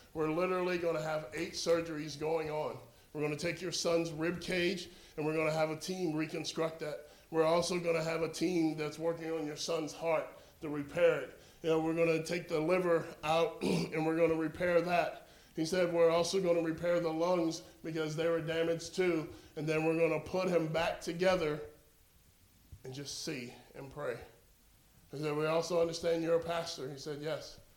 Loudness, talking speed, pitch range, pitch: -34 LUFS, 205 wpm, 155-170 Hz, 165 Hz